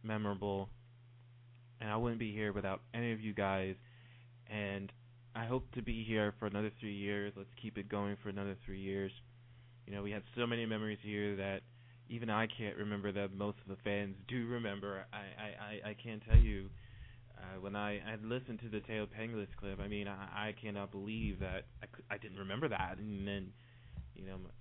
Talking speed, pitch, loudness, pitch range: 200 wpm, 105 Hz, -41 LUFS, 100-115 Hz